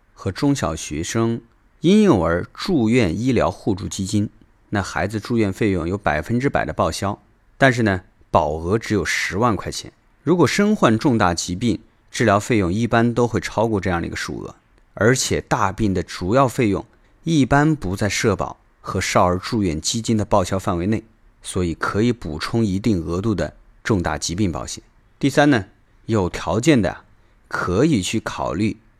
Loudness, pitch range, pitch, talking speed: -20 LUFS, 90-115 Hz, 105 Hz, 255 characters per minute